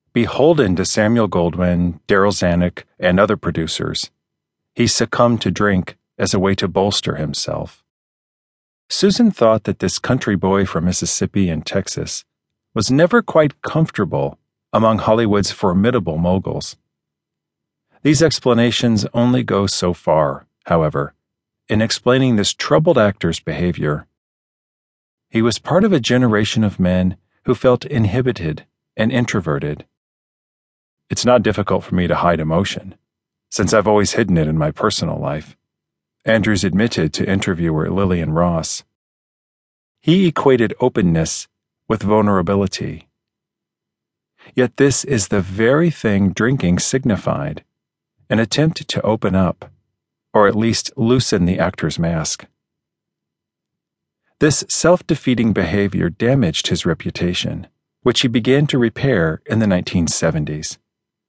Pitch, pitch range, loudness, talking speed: 105 Hz, 90-125 Hz, -17 LUFS, 125 wpm